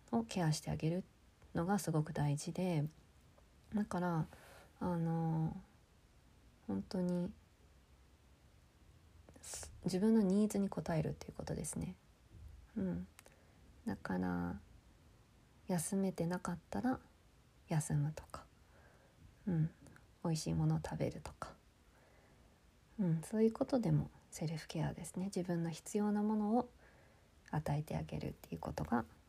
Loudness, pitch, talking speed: -39 LUFS, 155 Hz, 230 characters per minute